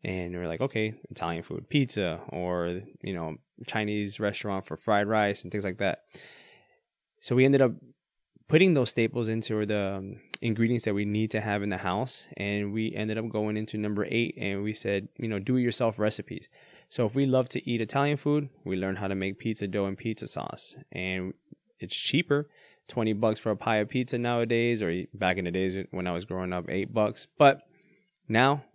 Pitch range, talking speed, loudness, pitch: 95-120 Hz, 205 wpm, -29 LUFS, 105 Hz